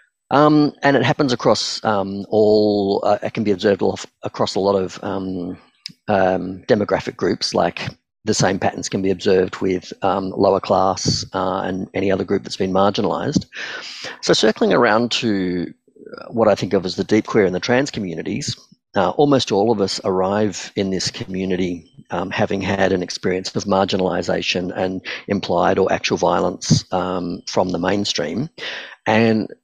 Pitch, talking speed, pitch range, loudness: 95 Hz, 165 wpm, 95-105 Hz, -19 LUFS